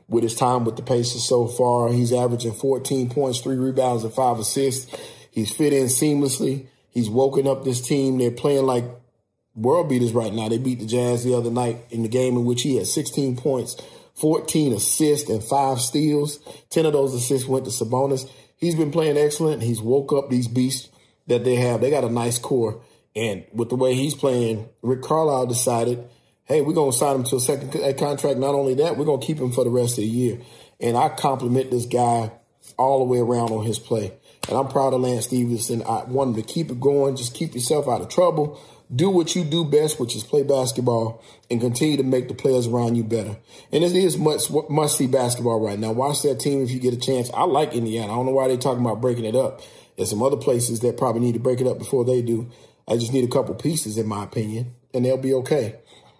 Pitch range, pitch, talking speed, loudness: 120-140 Hz, 125 Hz, 230 wpm, -21 LUFS